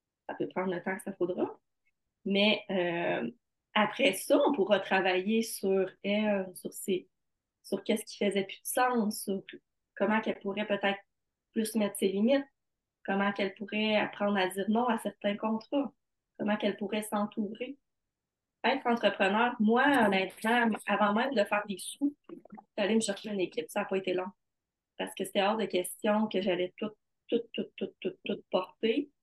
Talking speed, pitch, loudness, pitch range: 180 wpm, 205 Hz, -31 LUFS, 195-225 Hz